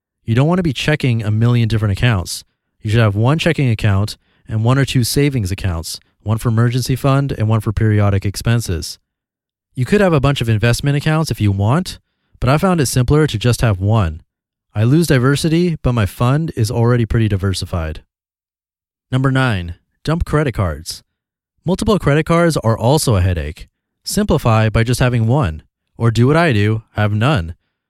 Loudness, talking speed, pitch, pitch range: -16 LUFS, 185 wpm, 115 Hz, 100-140 Hz